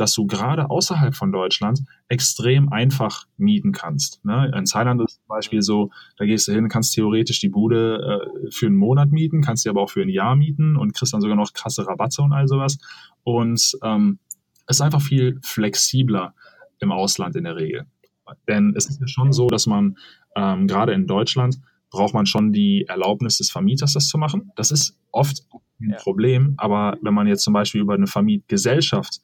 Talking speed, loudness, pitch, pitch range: 200 wpm, -19 LUFS, 125 Hz, 105-145 Hz